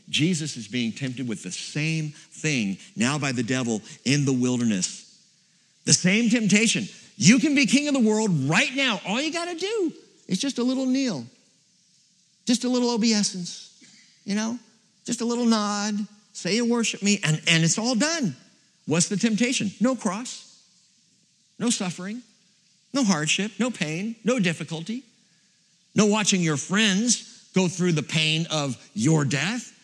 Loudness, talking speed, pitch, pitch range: -23 LUFS, 160 wpm, 205 Hz, 165-230 Hz